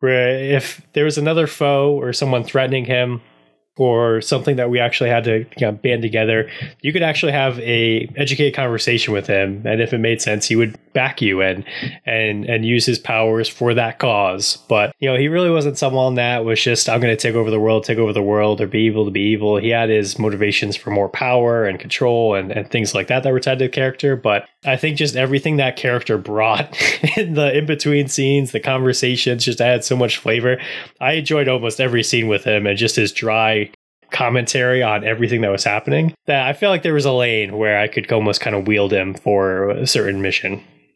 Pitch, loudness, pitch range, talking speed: 120 Hz, -17 LUFS, 110-135 Hz, 215 wpm